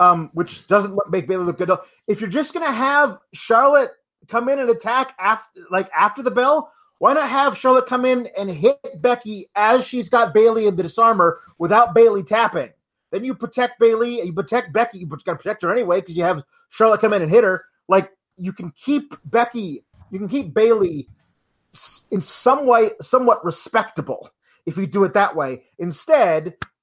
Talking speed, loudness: 195 wpm, -18 LUFS